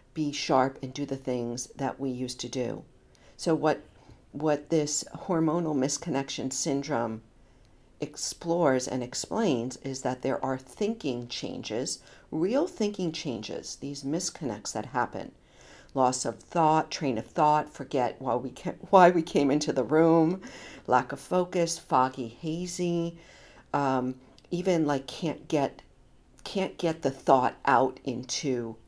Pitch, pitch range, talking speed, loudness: 140 Hz, 130-165 Hz, 135 wpm, -28 LUFS